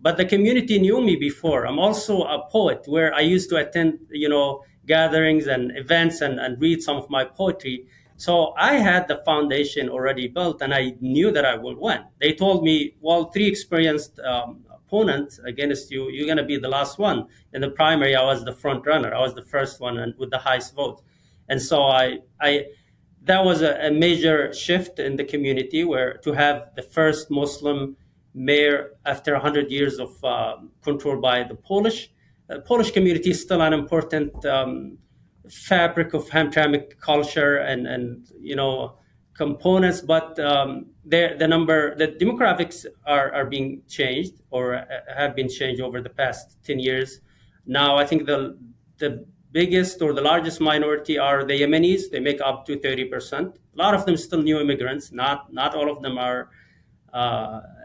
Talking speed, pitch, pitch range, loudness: 185 wpm, 145 Hz, 135-165 Hz, -22 LUFS